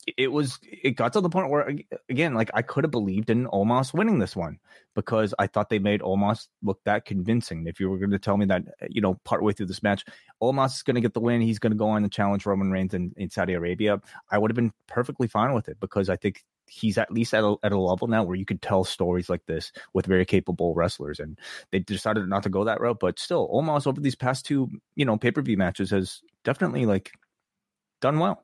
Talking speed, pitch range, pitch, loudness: 255 wpm, 95-120 Hz, 105 Hz, -26 LUFS